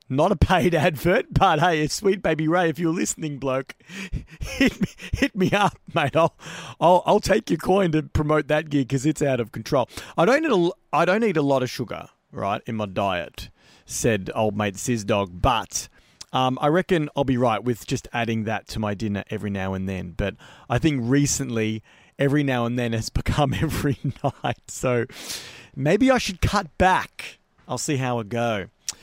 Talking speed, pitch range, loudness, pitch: 190 wpm, 120-165 Hz, -23 LUFS, 140 Hz